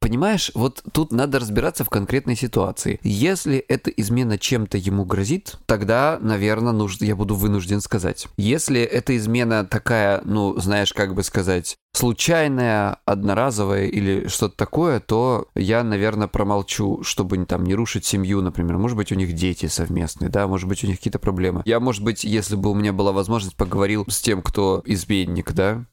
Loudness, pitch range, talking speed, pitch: -21 LUFS, 100-115 Hz, 170 wpm, 105 Hz